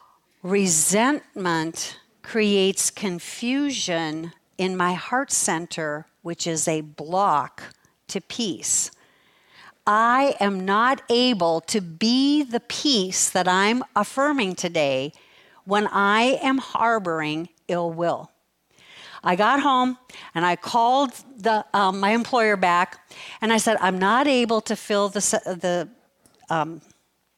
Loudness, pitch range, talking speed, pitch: -22 LUFS, 175-235 Hz, 115 wpm, 200 Hz